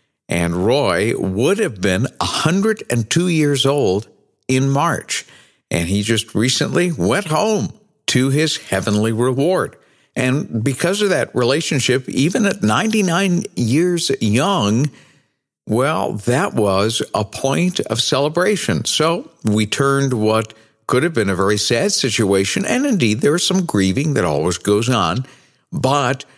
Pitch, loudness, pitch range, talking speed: 130 Hz, -17 LUFS, 110-160 Hz, 140 wpm